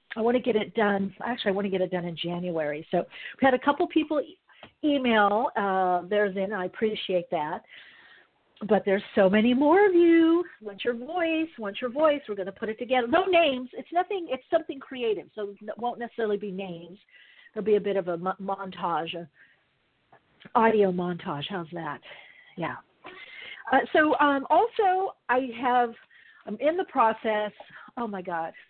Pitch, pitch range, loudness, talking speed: 220 Hz, 195-280 Hz, -26 LUFS, 180 wpm